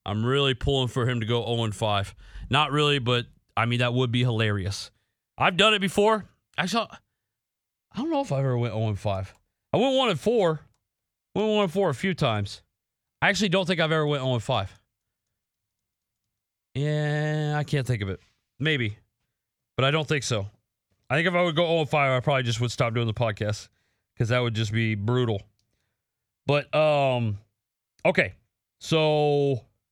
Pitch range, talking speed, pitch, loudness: 110-150 Hz, 170 wpm, 125 Hz, -25 LUFS